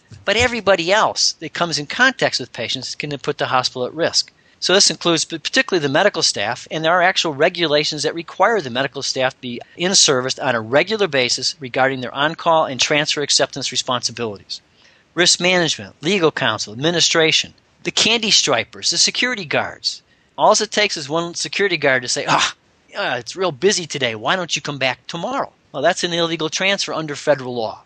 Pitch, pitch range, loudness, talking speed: 155 Hz, 130-175 Hz, -17 LUFS, 185 wpm